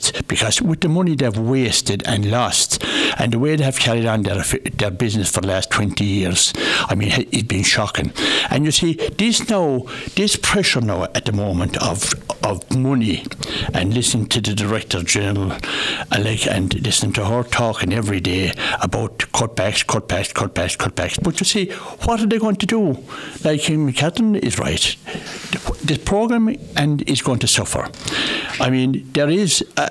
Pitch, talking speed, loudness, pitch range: 125 Hz, 170 wpm, -18 LUFS, 105-155 Hz